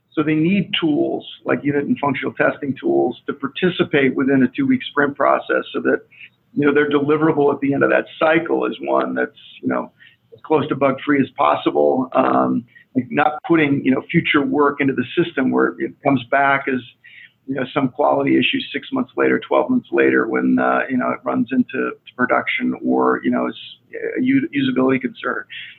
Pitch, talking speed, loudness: 140 Hz, 190 wpm, -18 LUFS